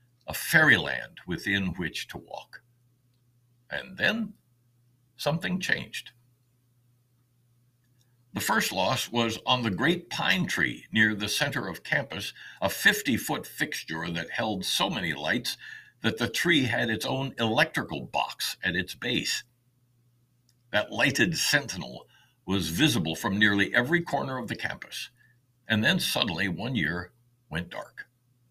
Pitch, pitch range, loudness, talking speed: 120 Hz, 115-125 Hz, -27 LUFS, 135 wpm